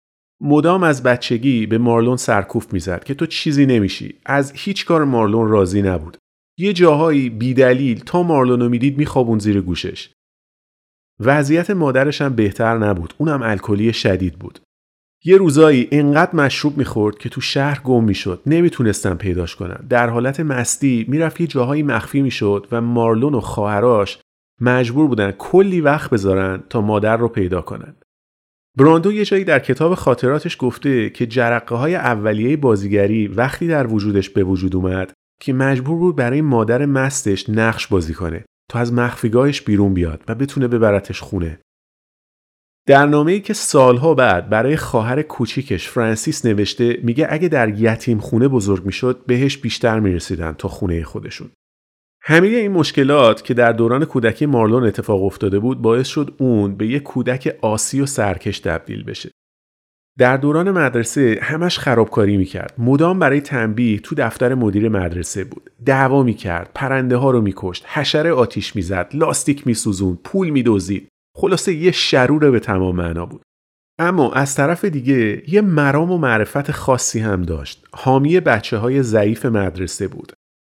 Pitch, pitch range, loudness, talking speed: 120 Hz, 100-140 Hz, -16 LUFS, 150 wpm